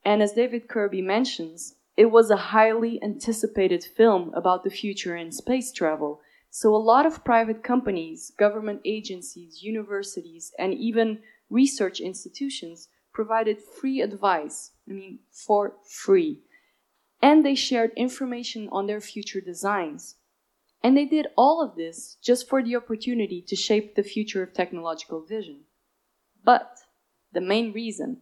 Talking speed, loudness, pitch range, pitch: 140 wpm, -24 LUFS, 190-240 Hz, 215 Hz